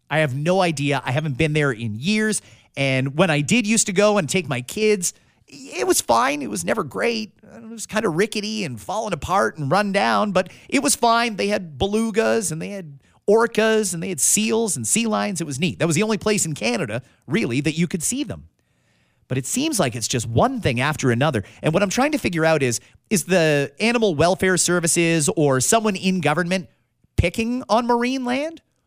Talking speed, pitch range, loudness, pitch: 215 wpm, 145-215 Hz, -20 LUFS, 185 Hz